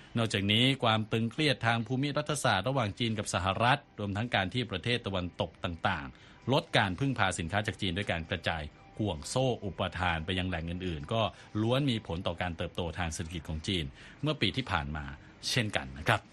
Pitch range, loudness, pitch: 90-120 Hz, -31 LUFS, 105 Hz